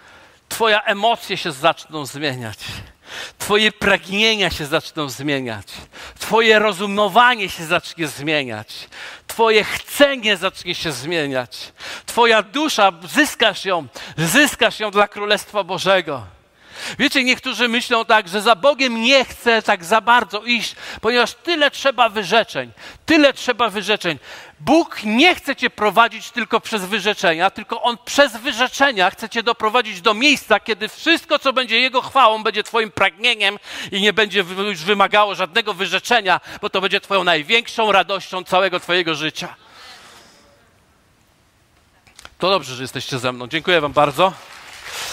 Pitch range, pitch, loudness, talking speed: 175-230 Hz, 210 Hz, -17 LUFS, 135 wpm